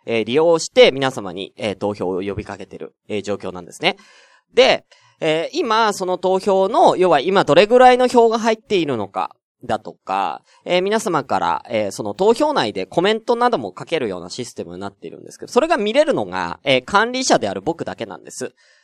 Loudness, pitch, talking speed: -18 LUFS, 175 Hz, 370 characters per minute